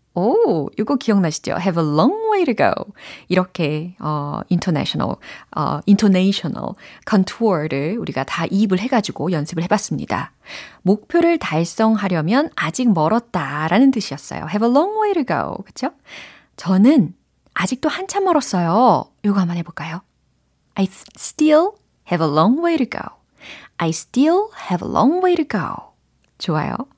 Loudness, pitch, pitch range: -19 LUFS, 205 Hz, 170-280 Hz